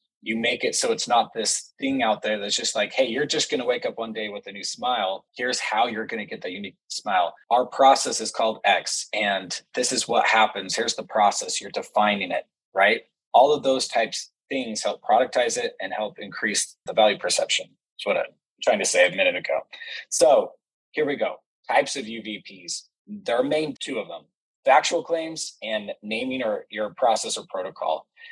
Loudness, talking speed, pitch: -24 LUFS, 210 wpm, 160 Hz